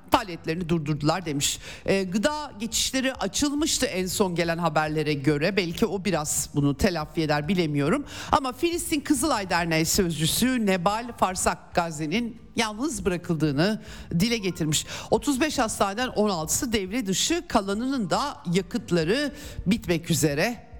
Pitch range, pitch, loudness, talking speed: 165-240 Hz, 195 Hz, -25 LUFS, 120 wpm